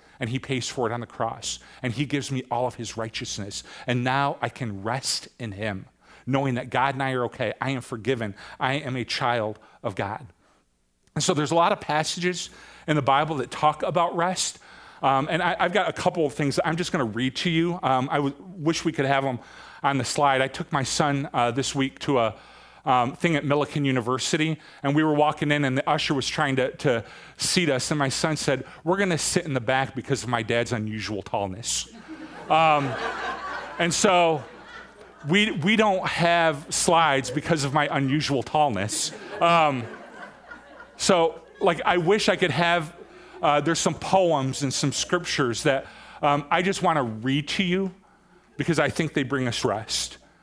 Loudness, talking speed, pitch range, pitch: -24 LUFS, 205 wpm, 130-165 Hz, 145 Hz